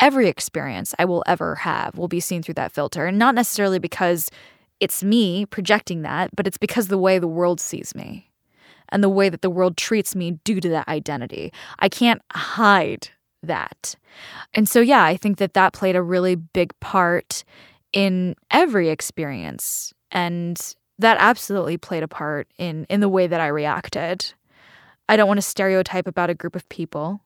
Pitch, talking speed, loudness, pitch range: 185 Hz, 185 wpm, -20 LUFS, 170-200 Hz